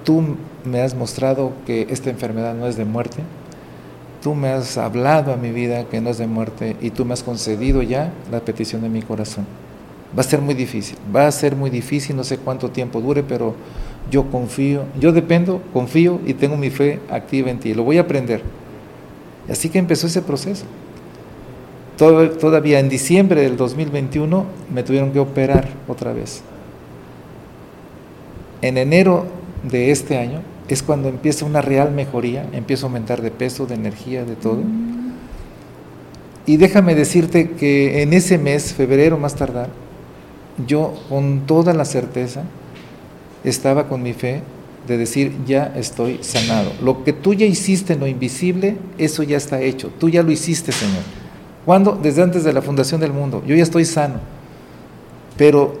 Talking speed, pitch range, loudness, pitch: 170 wpm, 125-155 Hz, -18 LUFS, 135 Hz